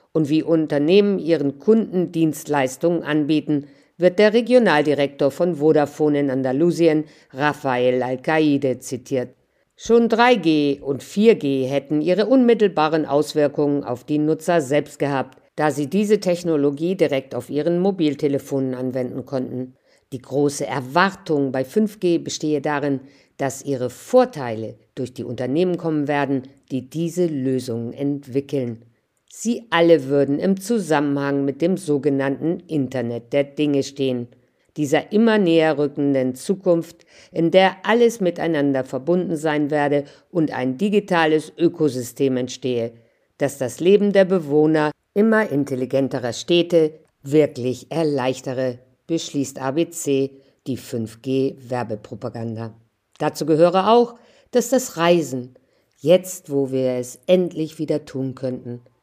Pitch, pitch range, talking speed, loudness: 145 Hz, 130-170 Hz, 120 wpm, -20 LUFS